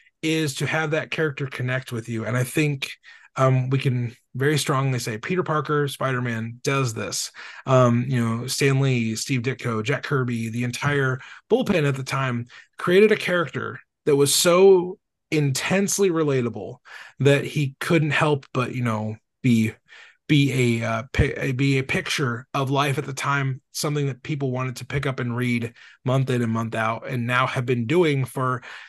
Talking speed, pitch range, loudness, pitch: 180 wpm, 125-150 Hz, -23 LUFS, 135 Hz